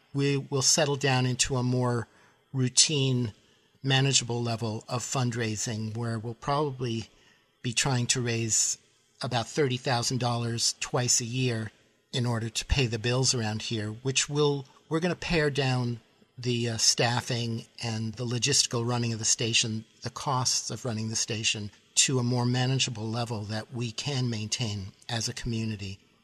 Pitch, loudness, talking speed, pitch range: 120 Hz, -27 LUFS, 155 wpm, 115-130 Hz